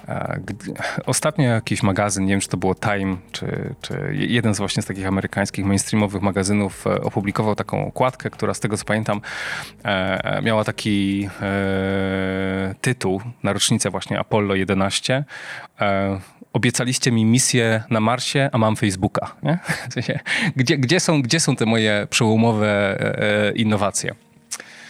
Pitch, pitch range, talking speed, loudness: 105 Hz, 100-125 Hz, 135 wpm, -21 LUFS